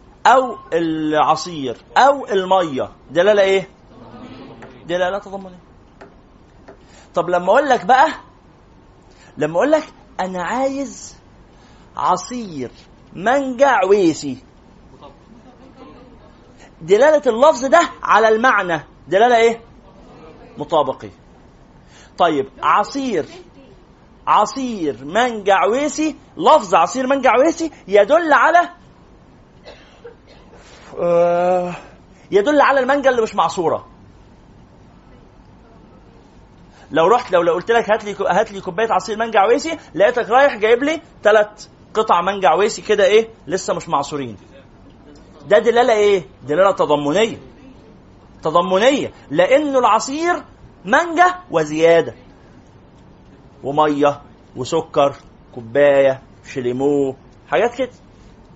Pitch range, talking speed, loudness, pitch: 160-265 Hz, 90 wpm, -16 LUFS, 205 Hz